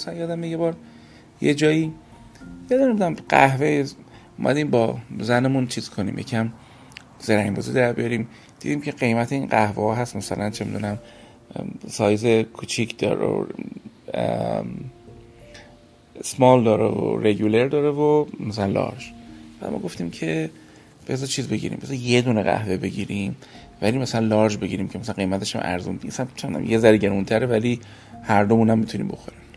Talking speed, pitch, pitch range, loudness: 155 wpm, 115 Hz, 105-125 Hz, -22 LUFS